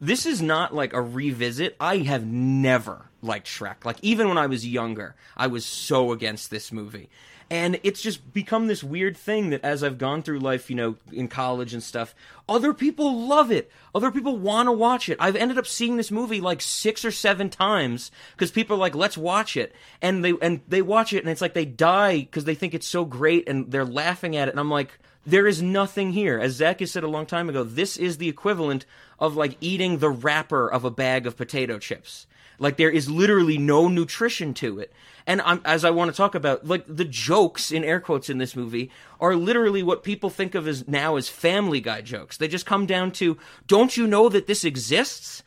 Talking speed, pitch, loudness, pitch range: 225 wpm, 165 Hz, -23 LUFS, 135-195 Hz